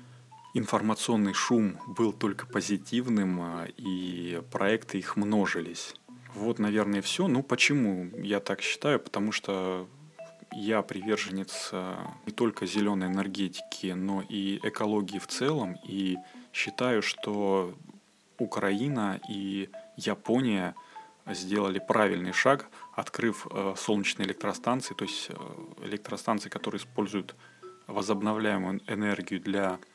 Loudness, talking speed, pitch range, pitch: -30 LUFS, 100 wpm, 95-110 Hz, 100 Hz